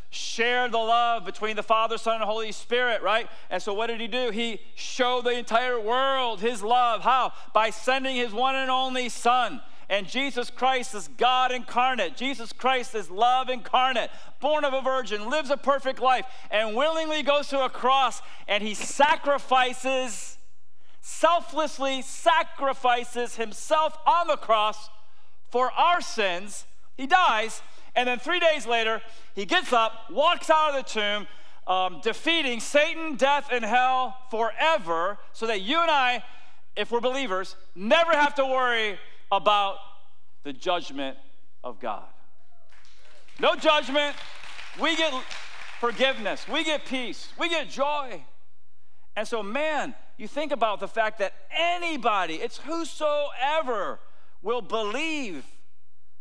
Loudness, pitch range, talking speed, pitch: -25 LUFS, 215-285 Hz, 140 wpm, 245 Hz